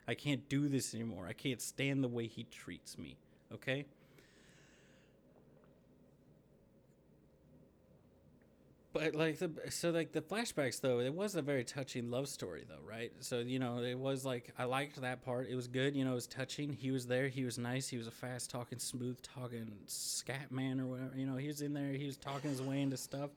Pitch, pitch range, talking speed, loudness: 130 Hz, 125-140 Hz, 205 wpm, -40 LUFS